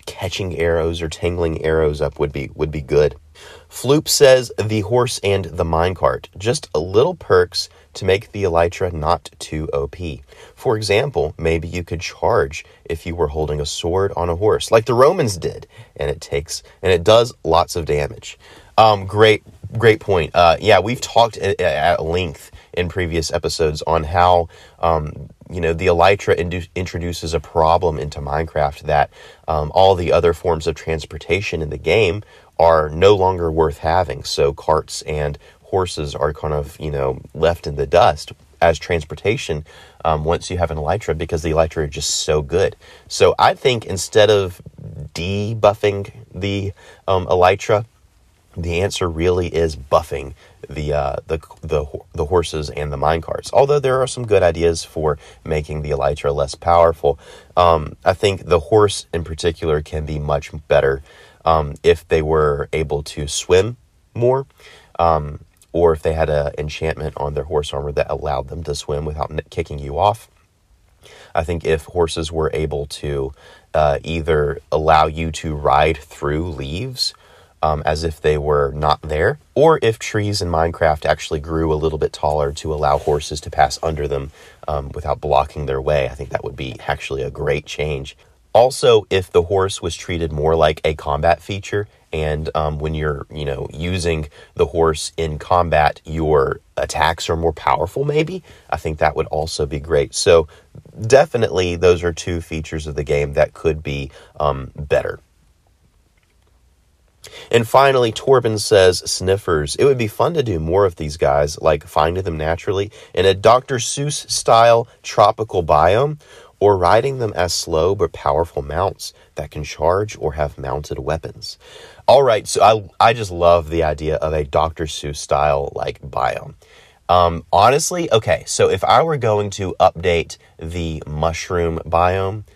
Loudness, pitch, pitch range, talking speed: -18 LUFS, 80 Hz, 75-95 Hz, 170 wpm